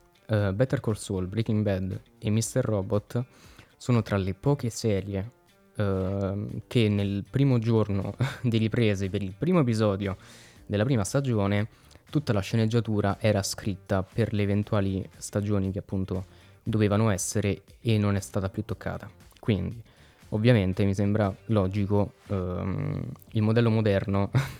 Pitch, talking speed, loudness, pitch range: 105 Hz, 135 wpm, -27 LUFS, 100-115 Hz